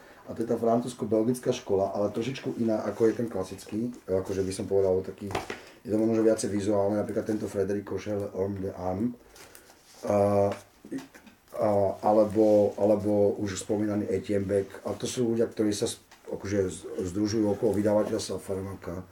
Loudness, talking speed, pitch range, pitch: -28 LUFS, 145 wpm, 100-110 Hz, 105 Hz